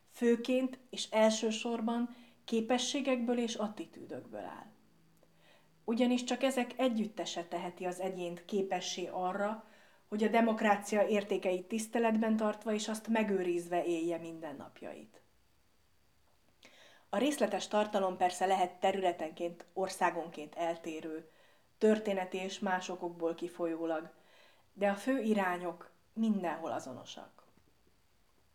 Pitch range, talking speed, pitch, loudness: 180-225 Hz, 95 wpm, 200 Hz, -34 LUFS